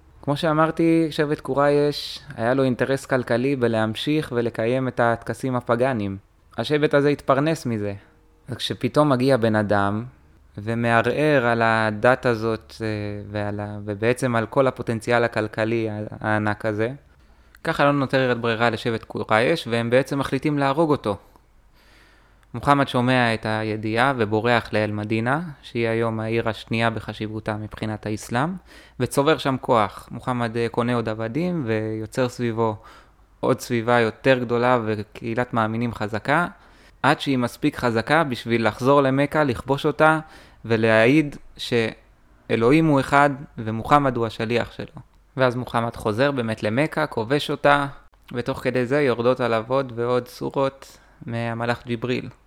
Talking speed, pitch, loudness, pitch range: 125 wpm, 120 Hz, -22 LUFS, 110-135 Hz